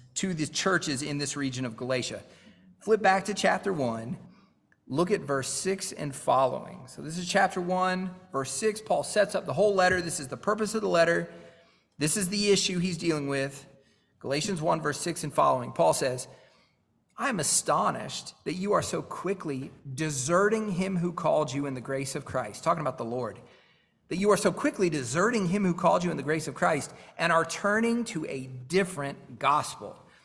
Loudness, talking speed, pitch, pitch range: -28 LUFS, 195 wpm, 165 Hz, 140-190 Hz